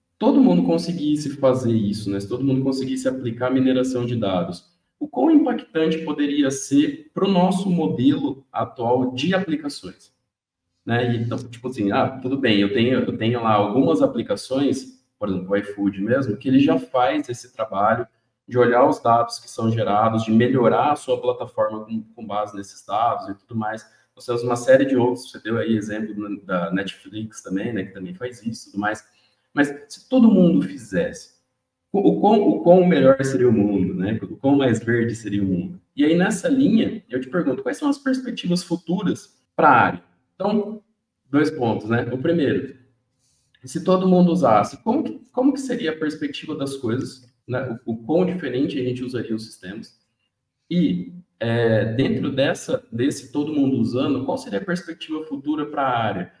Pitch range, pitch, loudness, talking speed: 115-165 Hz, 130 Hz, -21 LUFS, 185 wpm